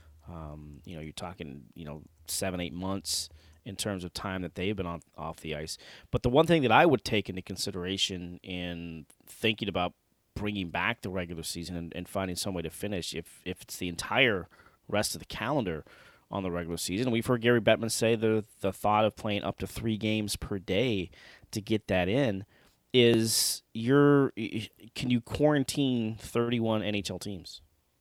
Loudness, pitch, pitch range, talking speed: -30 LUFS, 100 Hz, 85-110 Hz, 190 wpm